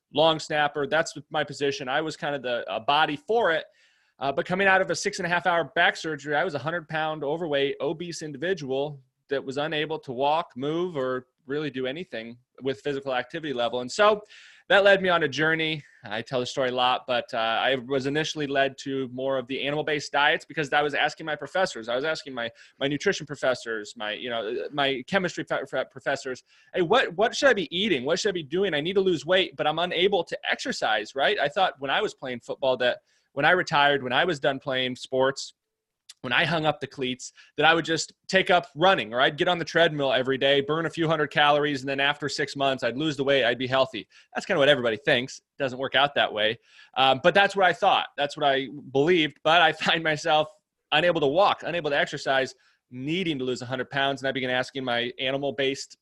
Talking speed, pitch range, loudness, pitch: 230 wpm, 135-165 Hz, -25 LUFS, 145 Hz